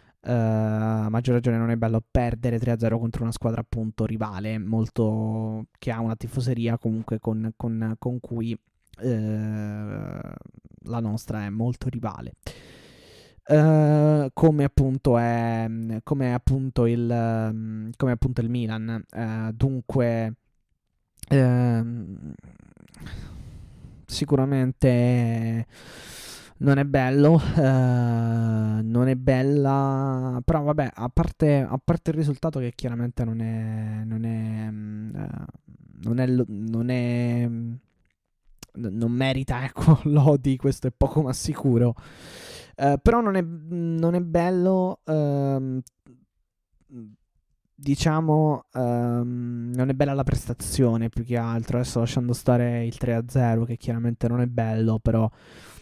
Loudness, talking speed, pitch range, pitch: -24 LUFS, 125 wpm, 115-135 Hz, 120 Hz